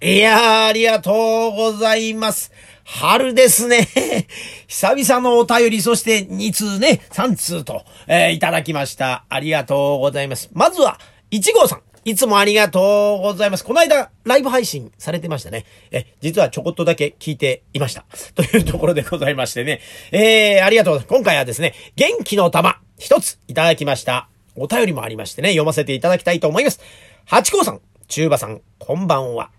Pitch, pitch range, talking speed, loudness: 190 Hz, 145-225 Hz, 370 characters per minute, -16 LUFS